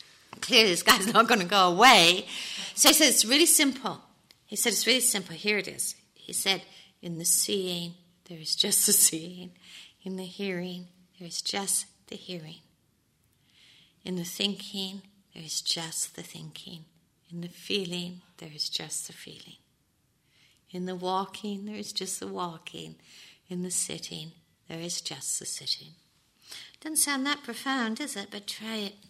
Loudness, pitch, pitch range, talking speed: -25 LUFS, 185 Hz, 170-210 Hz, 165 wpm